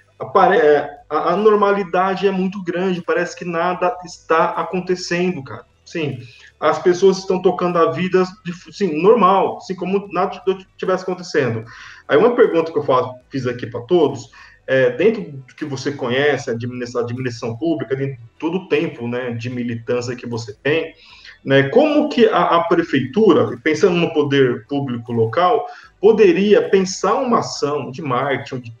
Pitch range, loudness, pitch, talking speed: 135-185 Hz, -18 LUFS, 165 Hz, 150 wpm